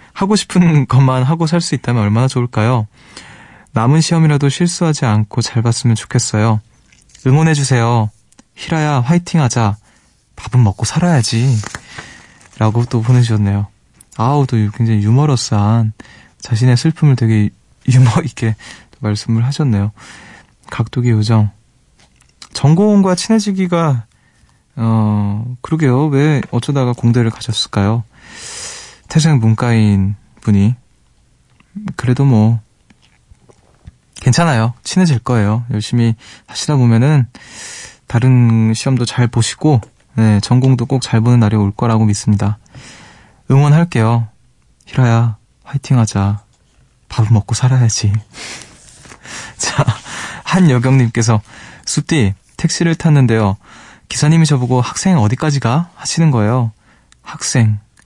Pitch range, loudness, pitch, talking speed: 110-140 Hz, -14 LUFS, 120 Hz, 260 characters per minute